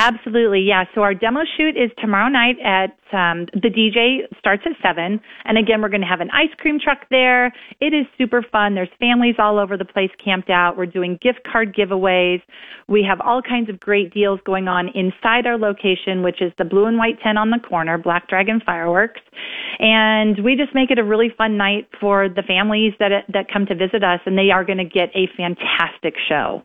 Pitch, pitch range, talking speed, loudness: 205 Hz, 190-235 Hz, 215 wpm, -17 LUFS